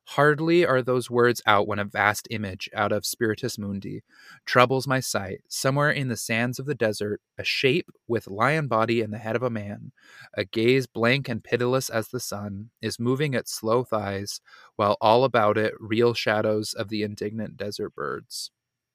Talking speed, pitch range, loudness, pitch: 185 wpm, 105-125 Hz, -25 LUFS, 115 Hz